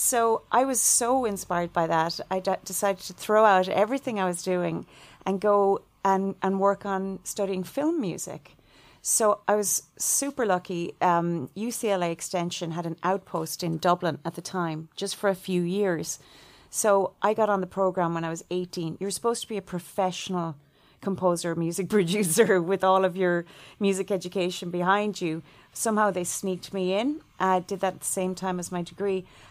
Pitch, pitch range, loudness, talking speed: 190 Hz, 175-200 Hz, -26 LUFS, 180 wpm